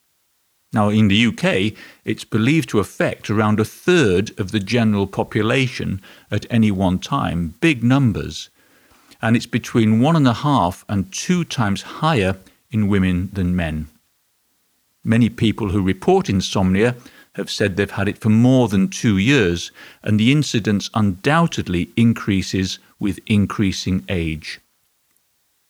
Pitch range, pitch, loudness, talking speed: 95-120 Hz, 105 Hz, -19 LUFS, 140 wpm